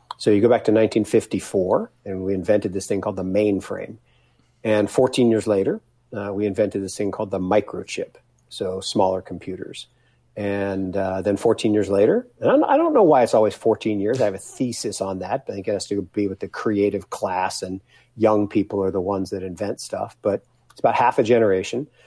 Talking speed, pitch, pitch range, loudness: 210 wpm, 100 Hz, 95-110 Hz, -21 LUFS